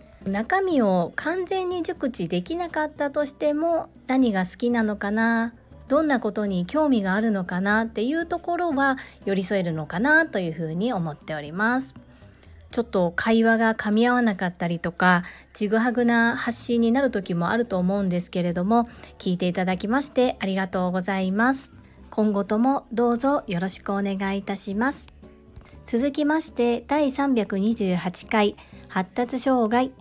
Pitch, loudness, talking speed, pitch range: 225 Hz, -24 LUFS, 325 characters per minute, 190-265 Hz